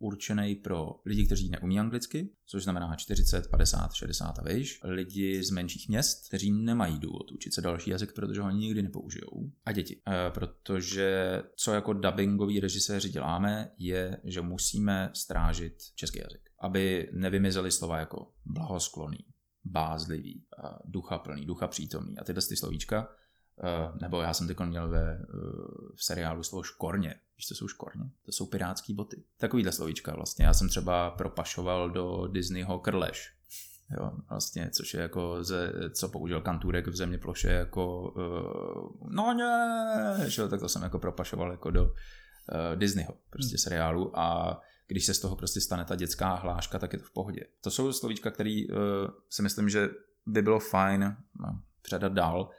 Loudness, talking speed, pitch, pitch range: -32 LUFS, 165 wpm, 95 Hz, 90-100 Hz